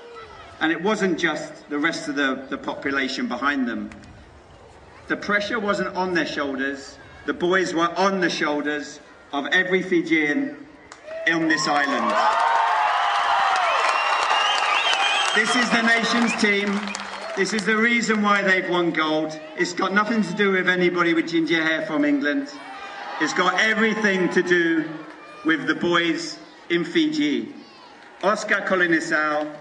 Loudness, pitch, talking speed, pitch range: -21 LUFS, 175 Hz, 135 wpm, 150-215 Hz